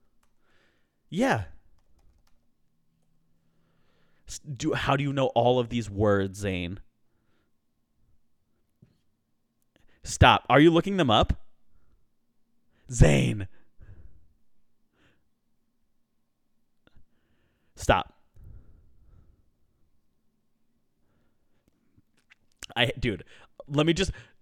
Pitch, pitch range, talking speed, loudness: 100 Hz, 85-125 Hz, 60 wpm, -25 LUFS